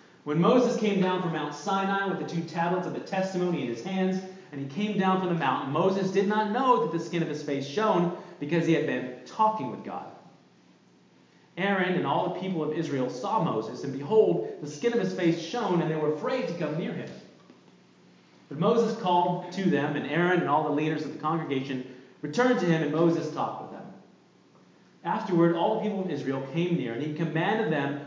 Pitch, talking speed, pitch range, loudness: 170 Hz, 215 wpm, 150-195 Hz, -27 LUFS